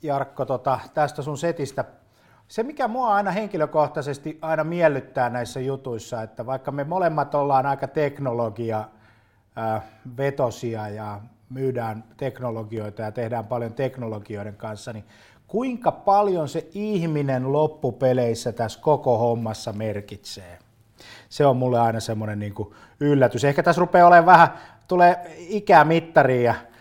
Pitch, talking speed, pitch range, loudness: 130 Hz, 120 wpm, 115-155 Hz, -22 LUFS